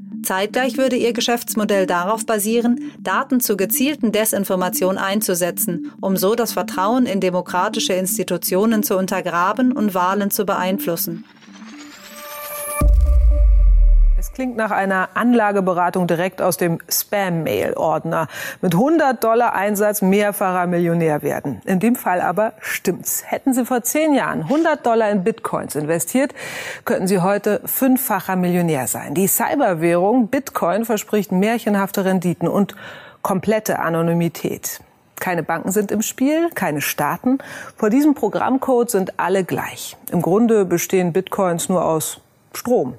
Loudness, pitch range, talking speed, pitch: -19 LUFS, 180-230 Hz, 125 wpm, 200 Hz